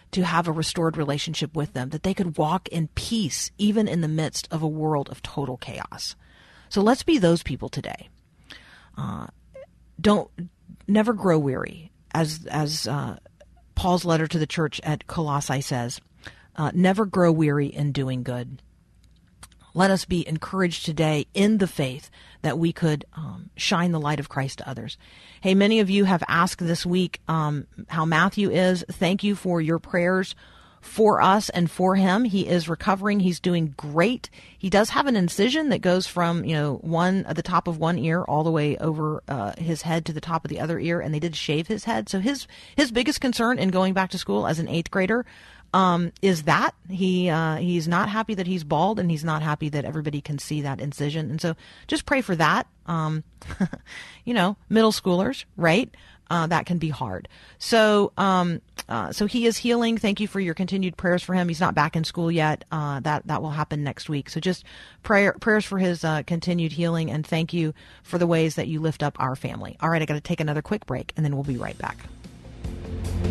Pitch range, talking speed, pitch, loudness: 150-190 Hz, 205 wpm, 165 Hz, -24 LUFS